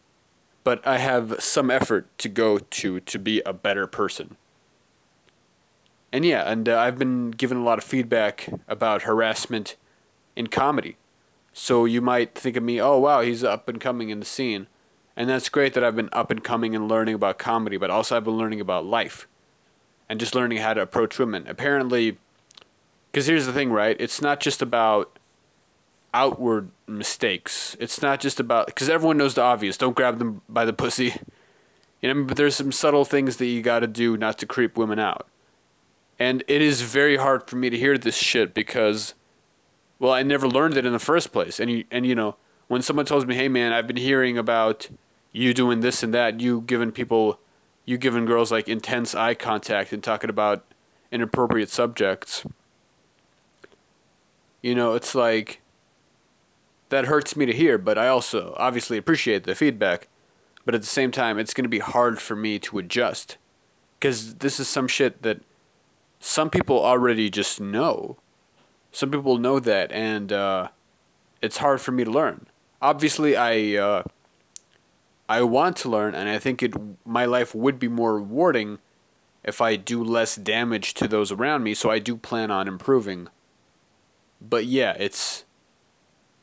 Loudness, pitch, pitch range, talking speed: -22 LUFS, 120 Hz, 110-130 Hz, 180 wpm